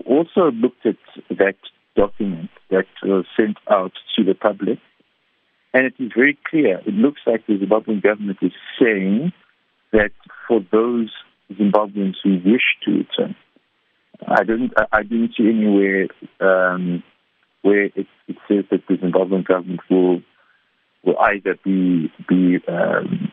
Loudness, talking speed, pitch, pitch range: -19 LUFS, 140 wpm, 100 Hz, 95-110 Hz